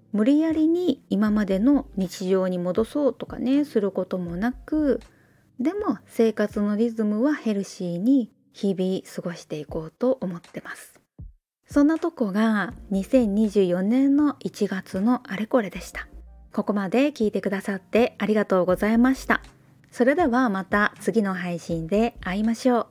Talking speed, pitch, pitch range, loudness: 295 characters per minute, 215 Hz, 190-255 Hz, -24 LUFS